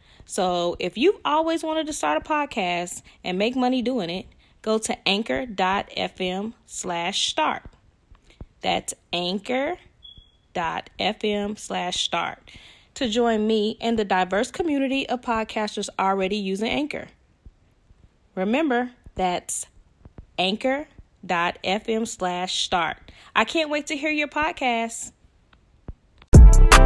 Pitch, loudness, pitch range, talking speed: 220 Hz, -24 LUFS, 185-260 Hz, 90 wpm